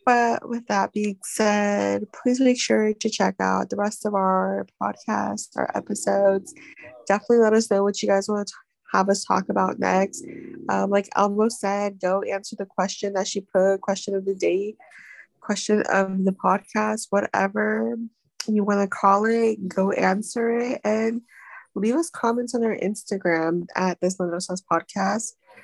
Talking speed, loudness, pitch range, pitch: 170 wpm, -23 LUFS, 195-225 Hz, 205 Hz